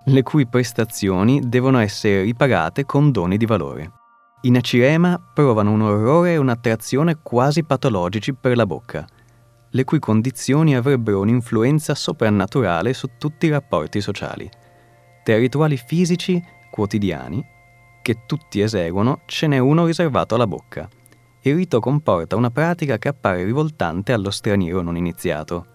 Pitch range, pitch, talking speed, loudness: 105-145 Hz, 120 Hz, 140 wpm, -19 LUFS